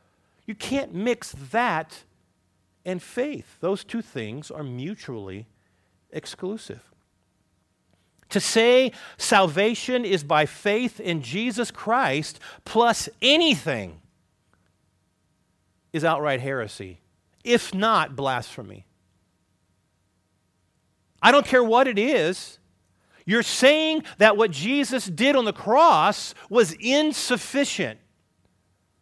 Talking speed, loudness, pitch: 95 wpm, -22 LUFS, 165 Hz